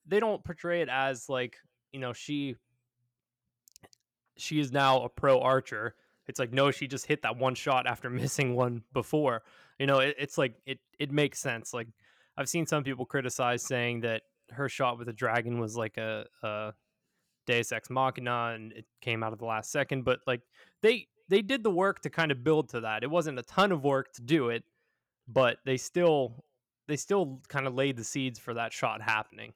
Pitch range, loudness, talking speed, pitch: 120-145 Hz, -30 LUFS, 205 wpm, 130 Hz